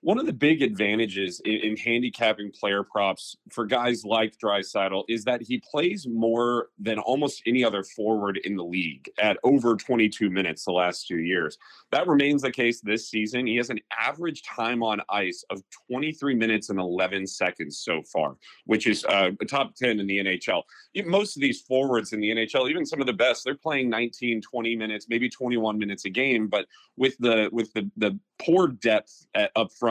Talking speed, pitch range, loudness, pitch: 195 wpm, 100-120 Hz, -25 LUFS, 110 Hz